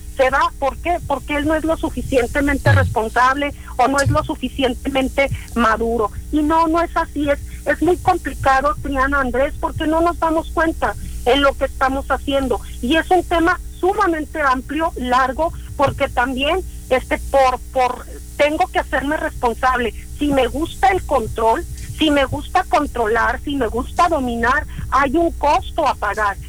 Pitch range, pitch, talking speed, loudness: 255-325 Hz, 285 Hz, 165 wpm, -18 LUFS